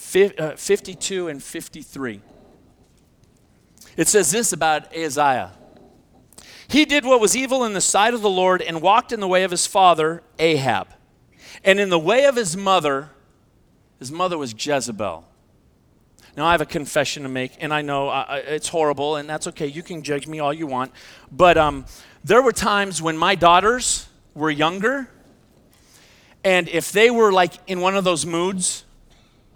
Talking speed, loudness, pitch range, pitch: 165 wpm, -19 LUFS, 150-190 Hz, 170 Hz